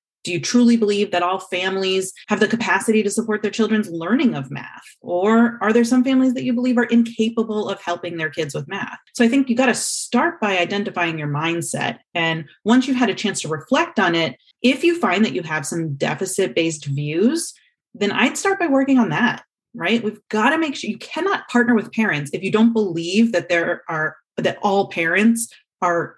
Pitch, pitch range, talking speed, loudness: 215 Hz, 175-240 Hz, 210 wpm, -19 LUFS